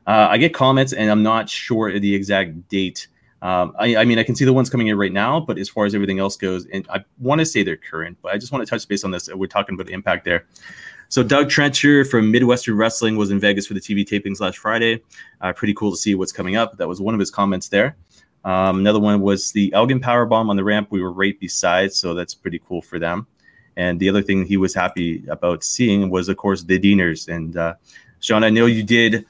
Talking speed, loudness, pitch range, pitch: 255 wpm, -18 LUFS, 95-115 Hz, 100 Hz